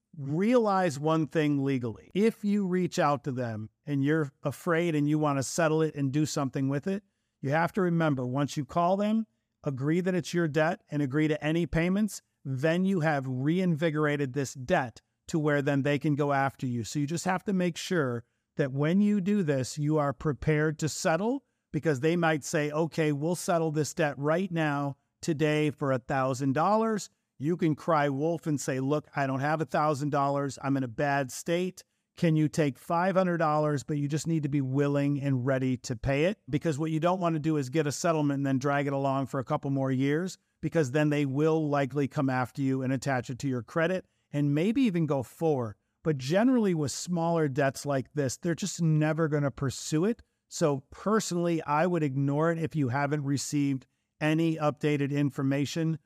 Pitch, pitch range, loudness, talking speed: 150 Hz, 140-165 Hz, -29 LUFS, 200 wpm